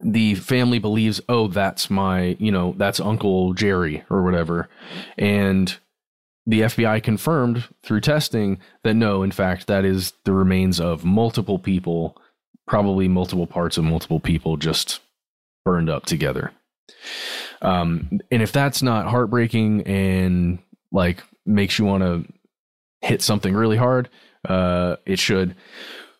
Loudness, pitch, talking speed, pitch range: -21 LUFS, 95 Hz, 135 wpm, 90-110 Hz